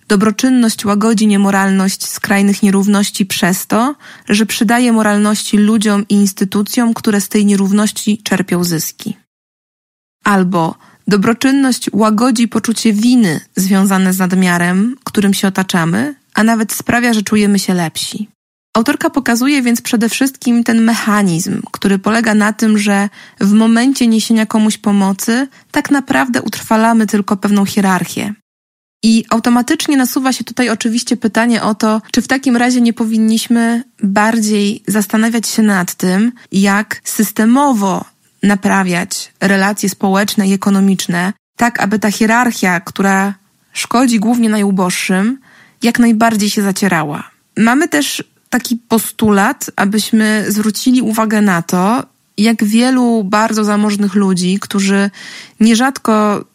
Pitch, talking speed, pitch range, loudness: 215 Hz, 120 wpm, 200-235 Hz, -13 LUFS